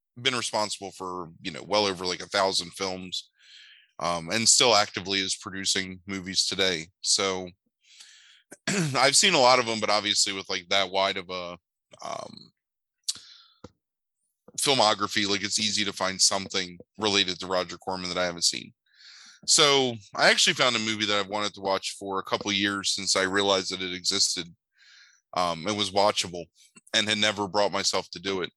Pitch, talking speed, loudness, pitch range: 95 Hz, 175 wpm, -24 LUFS, 95-105 Hz